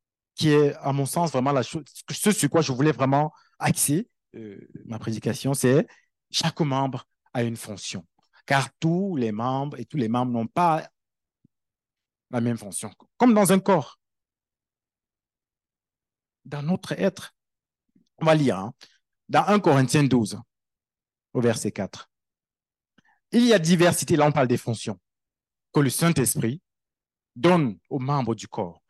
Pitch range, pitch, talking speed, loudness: 120-160 Hz, 135 Hz, 150 wpm, -23 LUFS